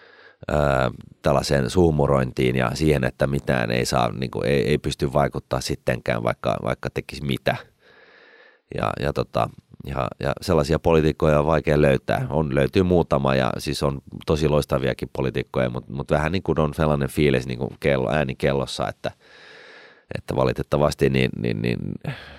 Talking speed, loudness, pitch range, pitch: 155 wpm, -22 LUFS, 65-75 Hz, 70 Hz